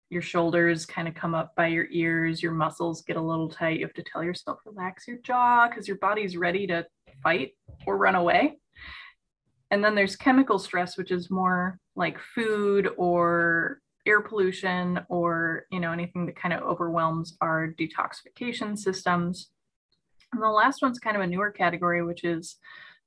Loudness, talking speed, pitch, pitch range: -26 LUFS, 175 wpm, 180 Hz, 170-200 Hz